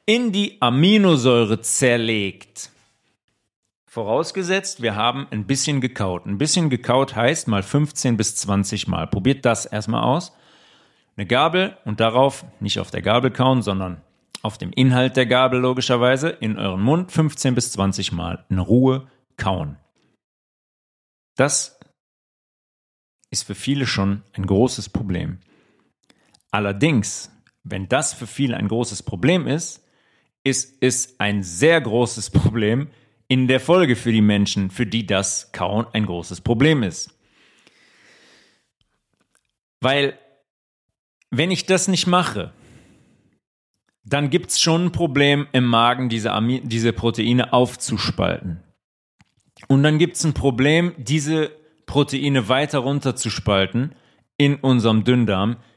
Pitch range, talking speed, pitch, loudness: 105-140 Hz, 125 wpm, 125 Hz, -20 LUFS